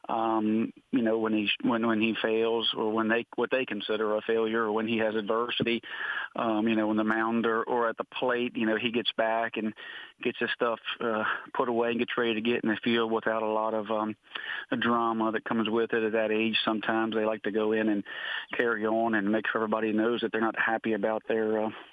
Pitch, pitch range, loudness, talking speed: 110 Hz, 110-115 Hz, -28 LUFS, 240 wpm